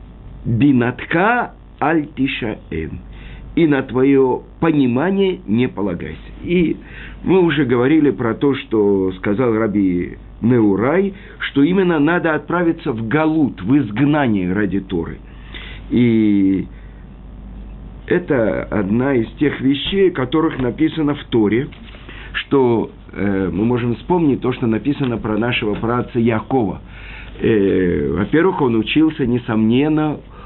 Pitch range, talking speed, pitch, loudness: 105-145 Hz, 110 wpm, 120 Hz, -17 LUFS